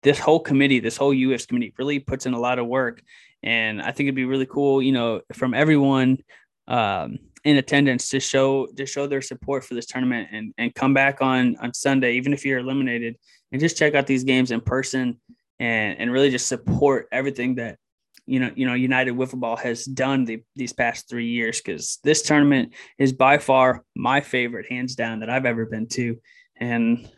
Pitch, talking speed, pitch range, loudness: 130 Hz, 205 wpm, 120-135 Hz, -22 LUFS